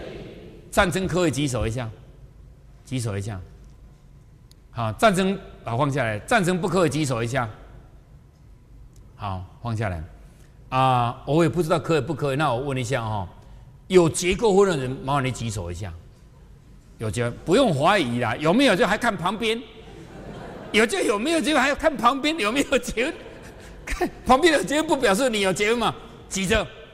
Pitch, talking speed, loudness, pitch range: 140 Hz, 245 characters per minute, -22 LUFS, 120-195 Hz